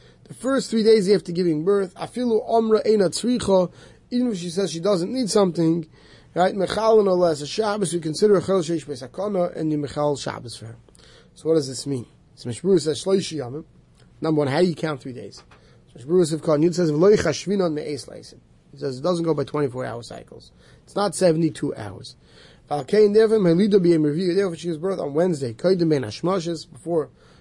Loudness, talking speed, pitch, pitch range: -22 LUFS, 185 wpm, 170 Hz, 145-195 Hz